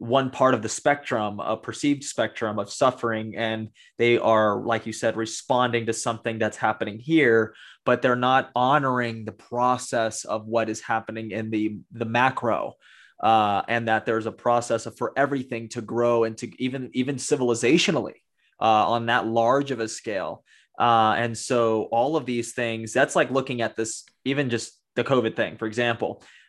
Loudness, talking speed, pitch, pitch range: -24 LUFS, 180 wpm, 115 Hz, 110-125 Hz